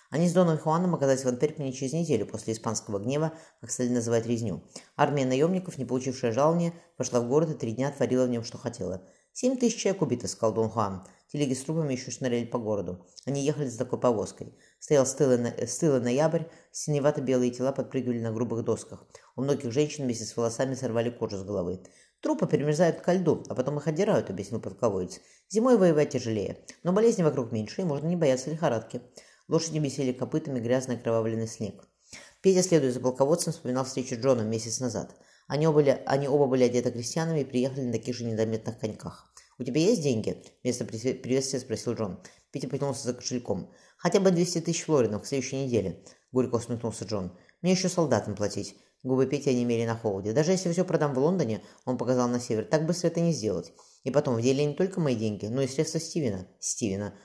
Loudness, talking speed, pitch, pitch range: -28 LUFS, 190 wpm, 130 Hz, 115-155 Hz